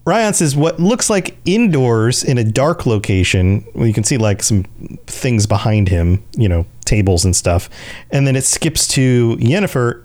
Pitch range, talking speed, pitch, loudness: 105-145 Hz, 185 wpm, 115 Hz, -14 LUFS